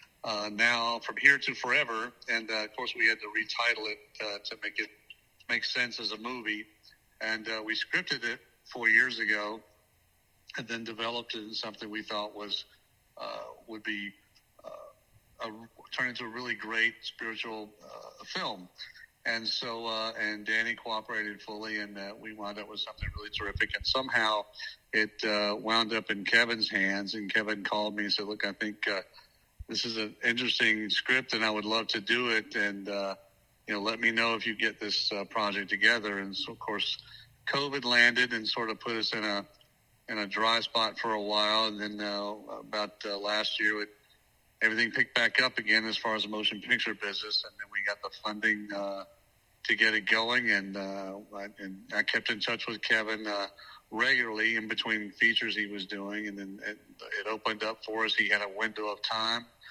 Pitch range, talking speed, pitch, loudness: 105-115 Hz, 200 wpm, 110 Hz, -30 LUFS